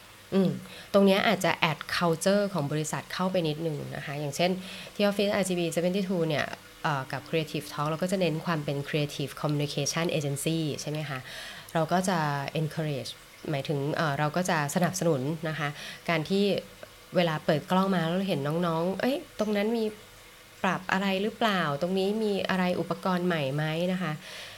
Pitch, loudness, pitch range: 165 Hz, -28 LUFS, 150-185 Hz